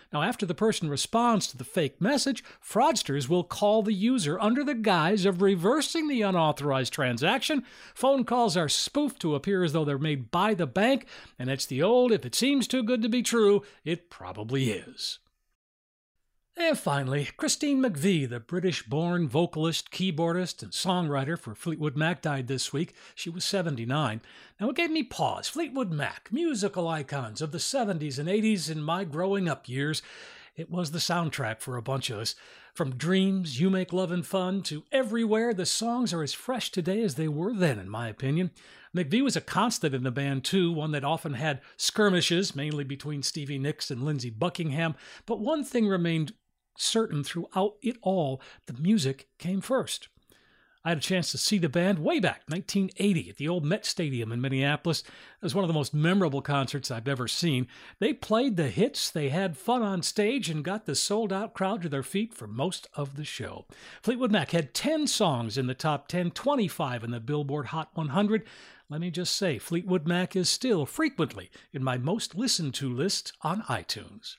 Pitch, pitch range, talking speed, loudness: 175 Hz, 145-210 Hz, 190 wpm, -28 LUFS